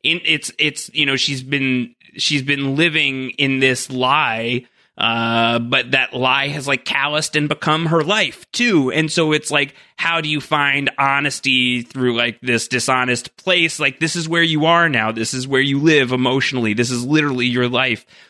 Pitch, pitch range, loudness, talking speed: 135 Hz, 125-155 Hz, -17 LUFS, 185 wpm